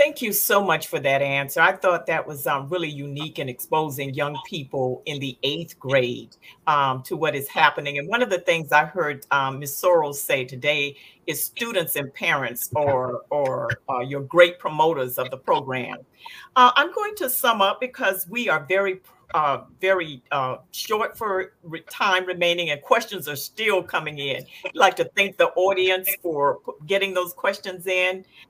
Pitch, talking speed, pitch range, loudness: 175 Hz, 180 wpm, 145-195 Hz, -22 LUFS